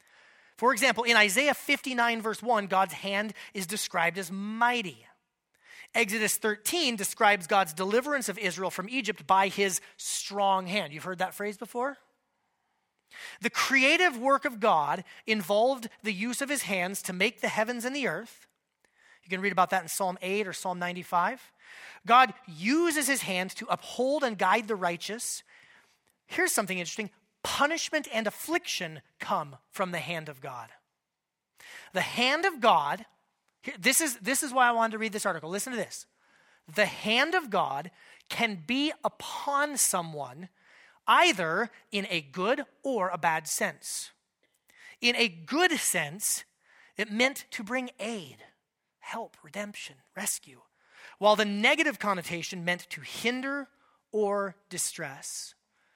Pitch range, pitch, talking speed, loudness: 190-260 Hz, 215 Hz, 145 wpm, -28 LUFS